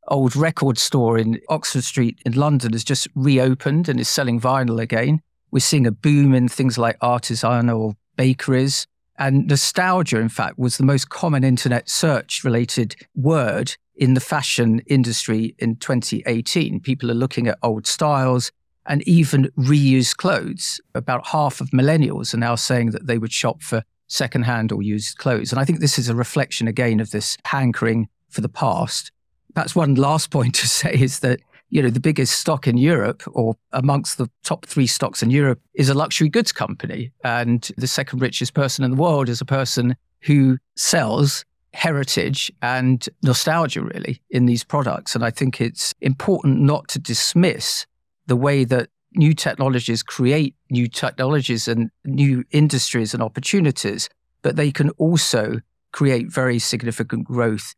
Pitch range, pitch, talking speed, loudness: 120-145 Hz, 130 Hz, 165 wpm, -19 LUFS